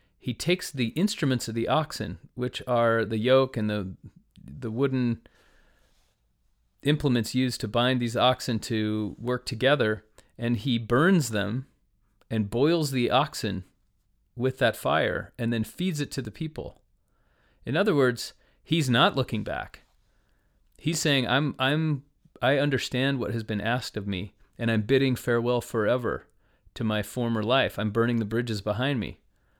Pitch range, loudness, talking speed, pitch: 110-135 Hz, -27 LUFS, 155 wpm, 120 Hz